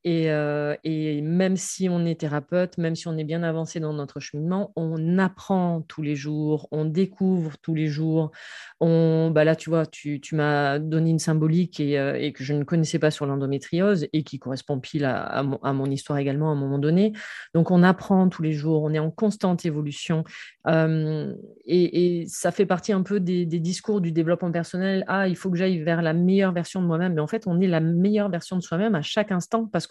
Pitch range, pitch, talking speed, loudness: 150-180 Hz, 165 Hz, 225 wpm, -24 LUFS